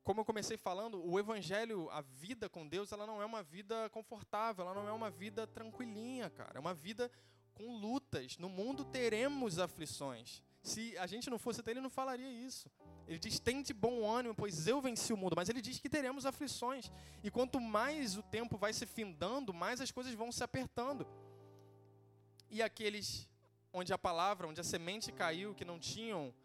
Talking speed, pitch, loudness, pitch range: 195 wpm, 215 Hz, -42 LUFS, 175-235 Hz